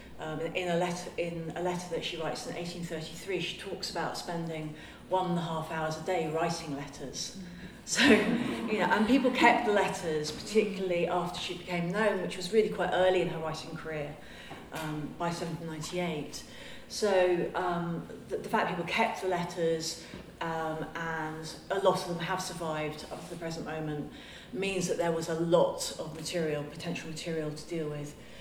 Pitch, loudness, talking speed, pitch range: 170 Hz, -32 LUFS, 180 wpm, 160-185 Hz